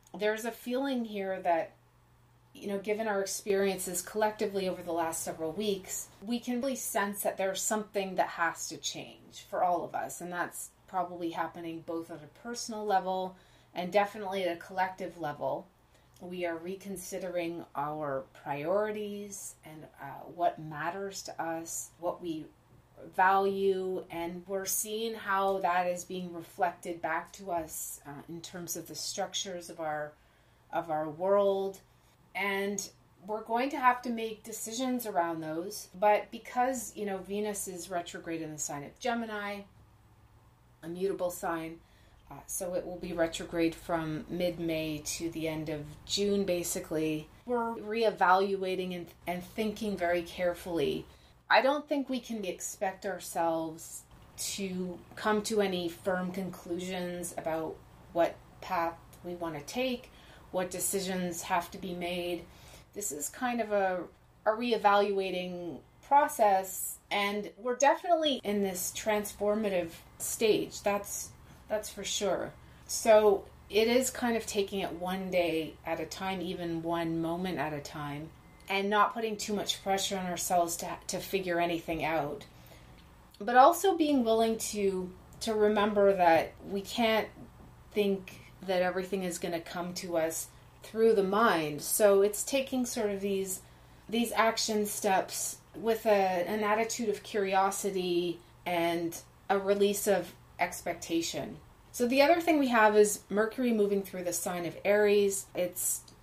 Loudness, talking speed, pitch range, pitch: -32 LUFS, 150 wpm, 170-210 Hz, 185 Hz